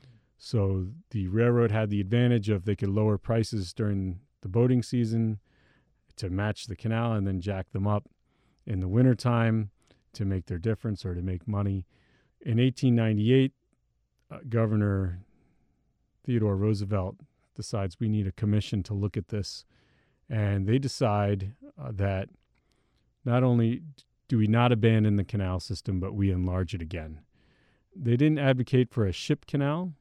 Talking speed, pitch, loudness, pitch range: 155 wpm, 110 Hz, -28 LUFS, 100-120 Hz